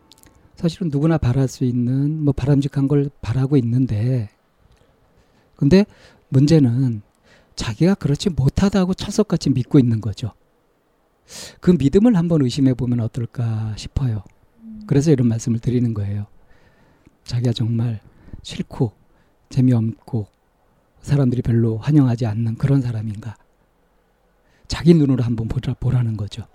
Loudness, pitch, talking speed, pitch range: -19 LUFS, 130 Hz, 275 characters per minute, 115-145 Hz